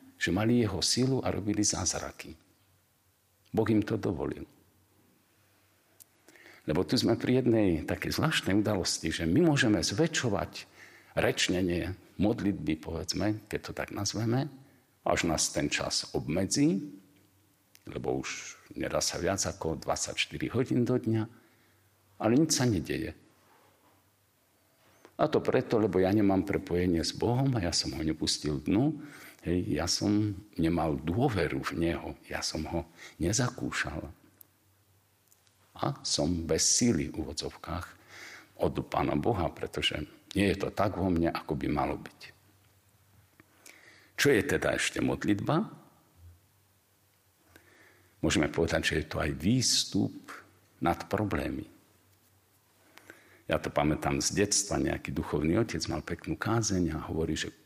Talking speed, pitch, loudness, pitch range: 130 wpm, 100 Hz, -30 LUFS, 90-110 Hz